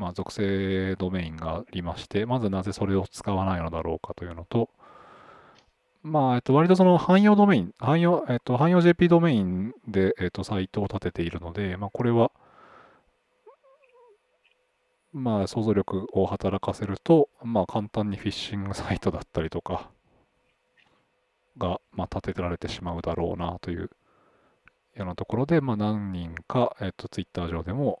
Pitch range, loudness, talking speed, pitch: 95-130 Hz, -26 LUFS, 300 characters per minute, 100 Hz